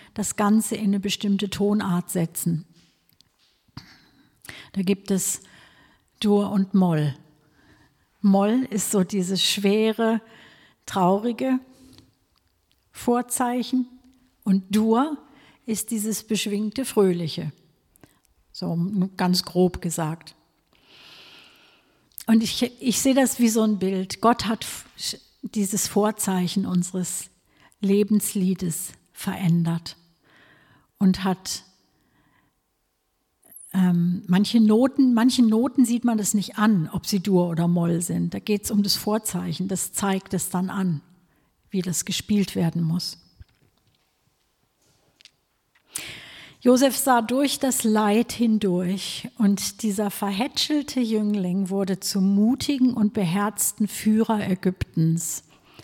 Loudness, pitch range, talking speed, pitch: -23 LUFS, 180-225 Hz, 105 wpm, 200 Hz